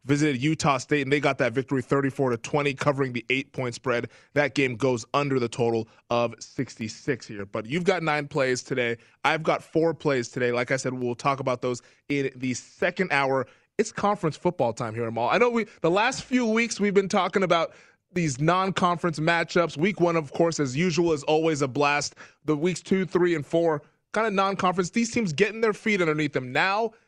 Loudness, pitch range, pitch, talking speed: -25 LUFS, 130-180 Hz, 150 Hz, 210 wpm